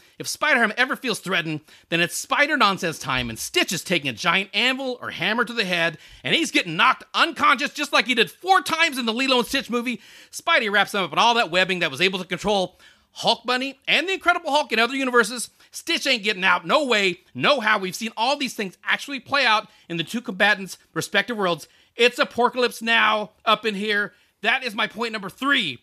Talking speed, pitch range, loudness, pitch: 225 wpm, 190-270 Hz, -21 LUFS, 225 Hz